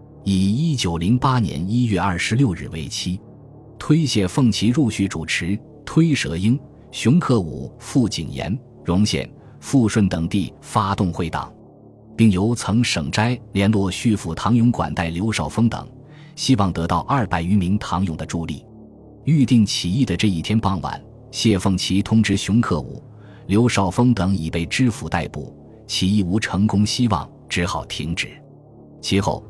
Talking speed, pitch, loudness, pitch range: 230 characters per minute, 105 Hz, -20 LUFS, 95-120 Hz